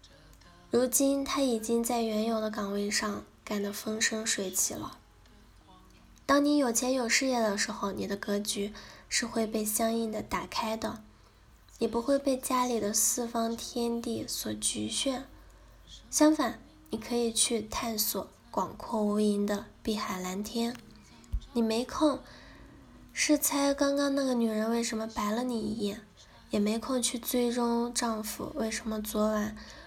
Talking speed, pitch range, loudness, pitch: 210 characters per minute, 215-245 Hz, -30 LUFS, 230 Hz